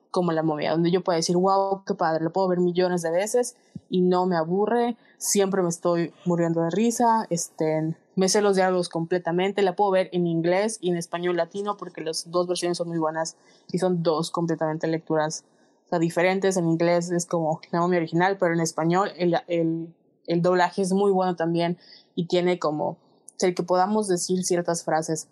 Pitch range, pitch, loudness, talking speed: 165-185 Hz, 175 Hz, -24 LUFS, 200 wpm